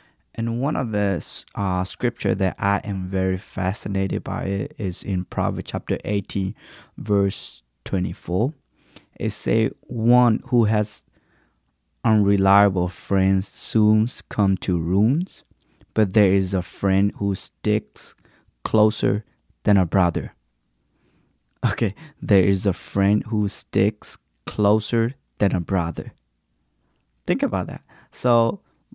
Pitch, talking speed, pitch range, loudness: 100 Hz, 120 wpm, 95-110 Hz, -22 LUFS